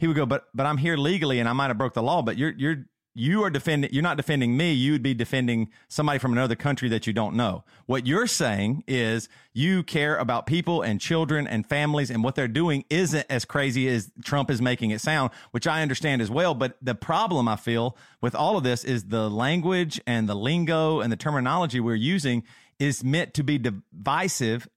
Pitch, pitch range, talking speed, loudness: 135 Hz, 120-155 Hz, 220 wpm, -25 LUFS